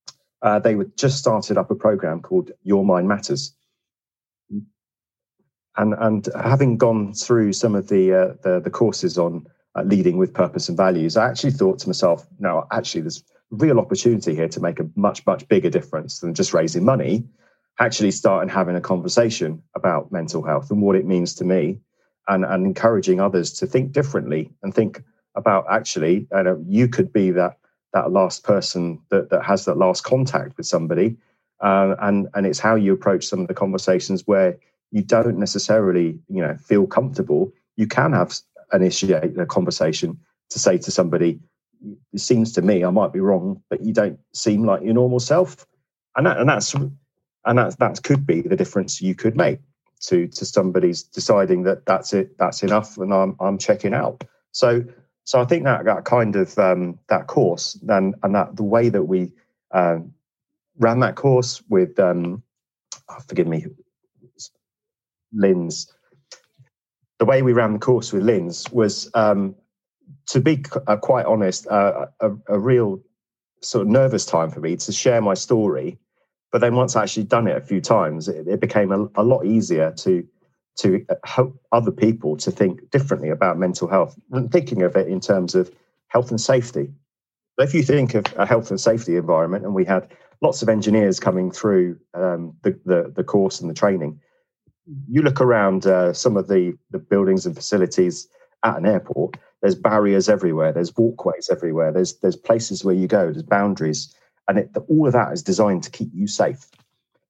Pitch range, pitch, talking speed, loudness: 95-125 Hz, 105 Hz, 185 wpm, -20 LUFS